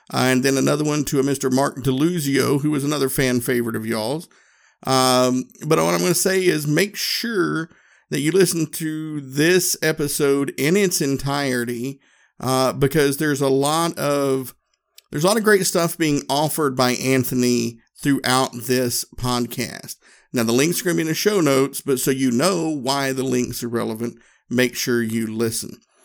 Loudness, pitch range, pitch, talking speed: -20 LUFS, 125-155 Hz, 140 Hz, 180 wpm